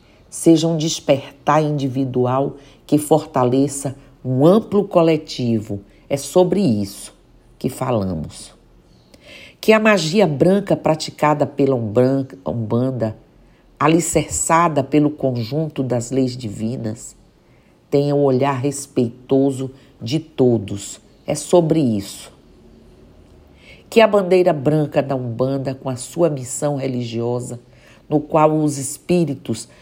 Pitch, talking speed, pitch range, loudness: 135 Hz, 105 wpm, 120-155 Hz, -18 LUFS